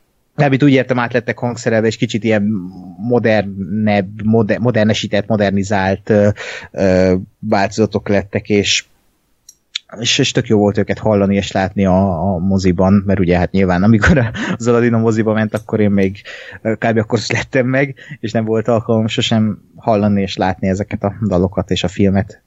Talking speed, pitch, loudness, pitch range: 160 wpm, 105 Hz, -15 LUFS, 100-115 Hz